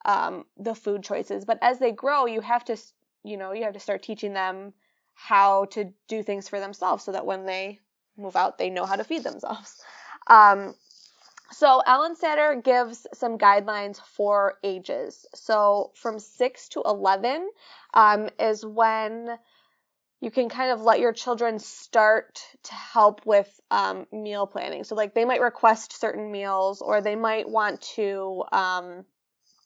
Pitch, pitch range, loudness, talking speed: 215 Hz, 200-235 Hz, -24 LUFS, 165 wpm